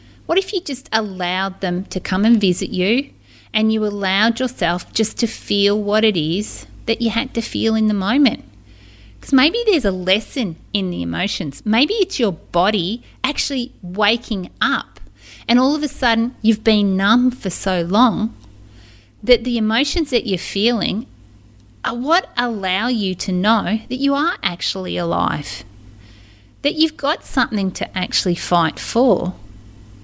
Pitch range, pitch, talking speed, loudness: 180-245 Hz, 215 Hz, 160 wpm, -18 LUFS